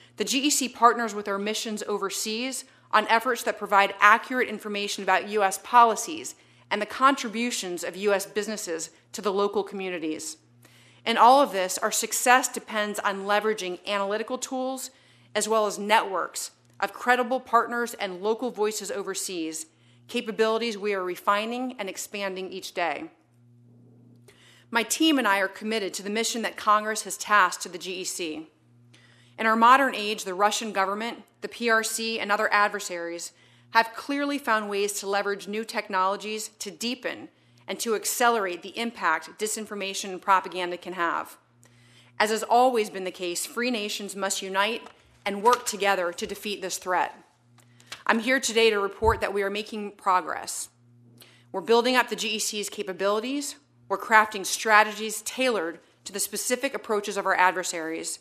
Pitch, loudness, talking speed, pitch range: 205 Hz, -25 LUFS, 155 wpm, 185-225 Hz